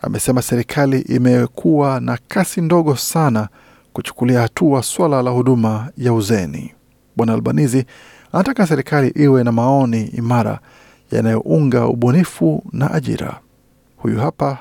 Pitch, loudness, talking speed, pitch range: 125 Hz, -16 LUFS, 115 wpm, 120-145 Hz